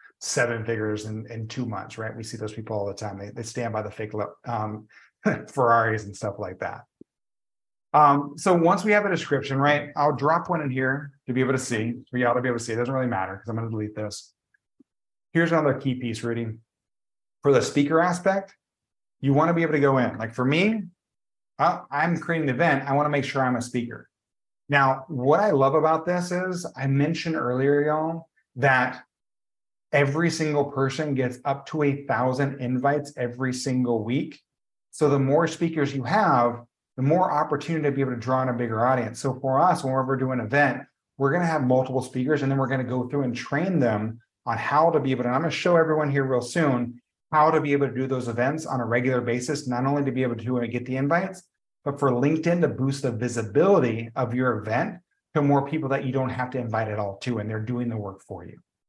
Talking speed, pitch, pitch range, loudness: 230 wpm, 130 Hz, 120-150 Hz, -24 LUFS